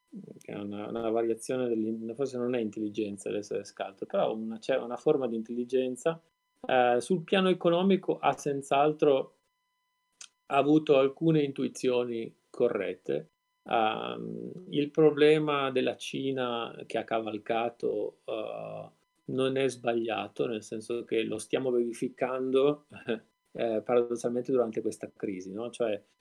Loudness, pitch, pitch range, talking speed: -30 LUFS, 130 Hz, 115-165 Hz, 120 wpm